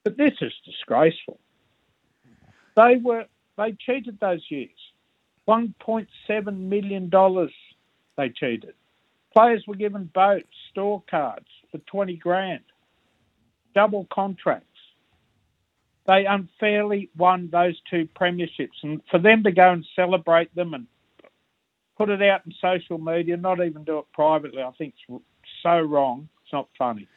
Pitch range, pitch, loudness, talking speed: 165-205 Hz, 185 Hz, -22 LUFS, 135 wpm